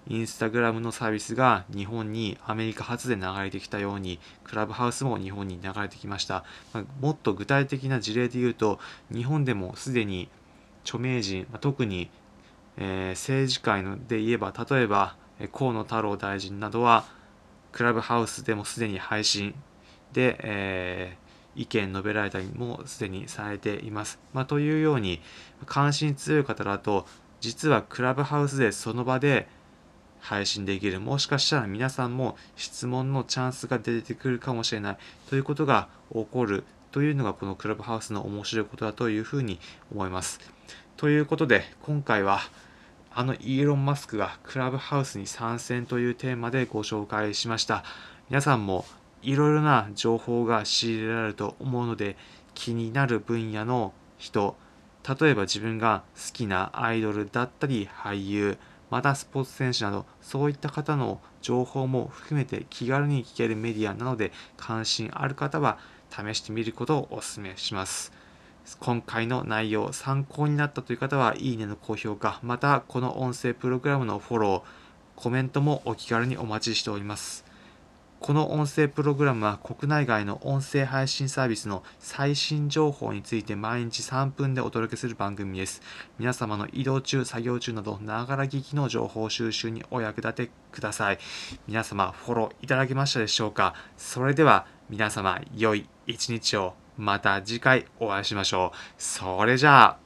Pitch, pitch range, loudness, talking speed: 115 Hz, 105-130 Hz, -28 LUFS, 335 characters per minute